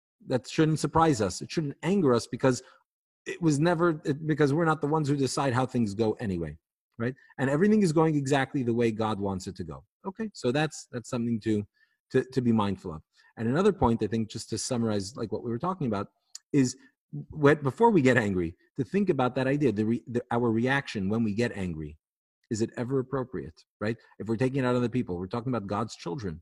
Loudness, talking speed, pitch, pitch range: -28 LUFS, 225 wpm, 125 Hz, 110-145 Hz